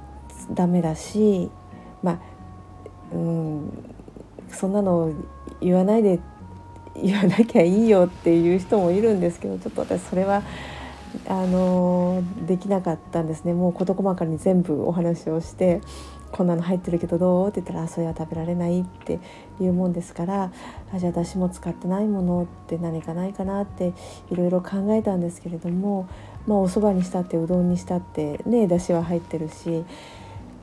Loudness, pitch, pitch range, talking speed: -23 LUFS, 175 Hz, 165-190 Hz, 340 characters per minute